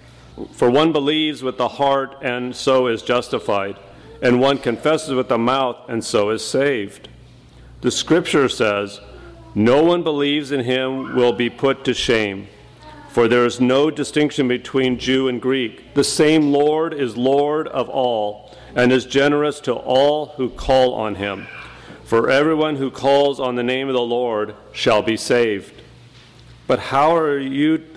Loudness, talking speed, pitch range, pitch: -18 LUFS, 160 wpm, 120-145 Hz, 130 Hz